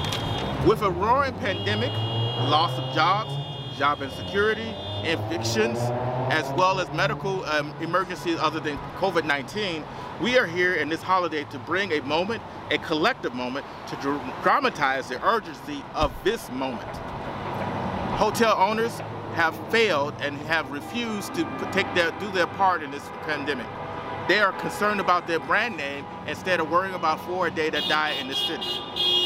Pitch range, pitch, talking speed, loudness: 135-180 Hz, 155 Hz, 150 wpm, -25 LUFS